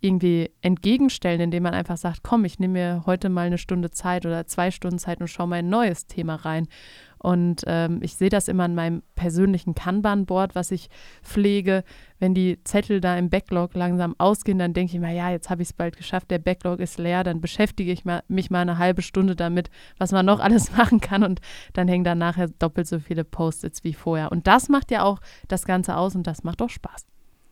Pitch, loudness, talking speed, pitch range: 180 Hz, -23 LUFS, 220 wpm, 175-190 Hz